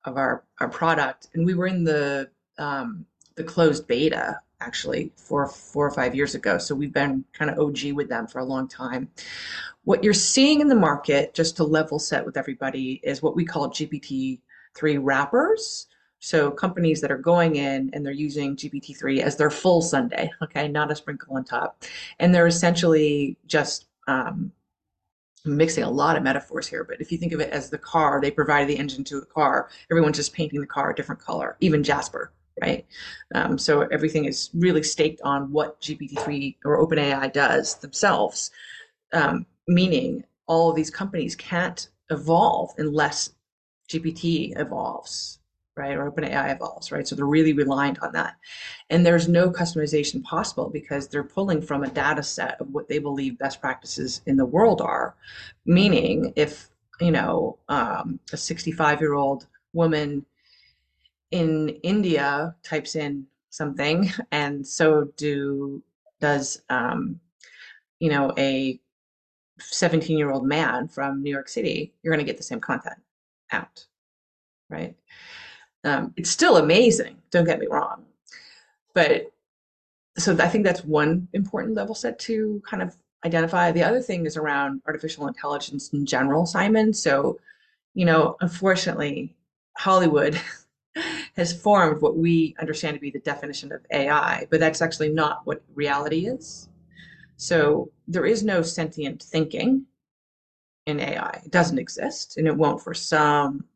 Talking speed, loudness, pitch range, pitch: 160 wpm, -23 LUFS, 140-170 Hz, 155 Hz